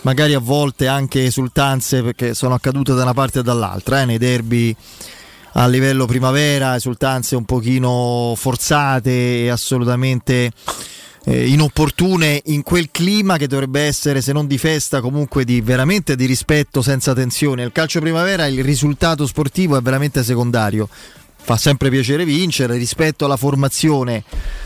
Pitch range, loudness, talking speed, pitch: 125-145 Hz, -16 LUFS, 145 wpm, 135 Hz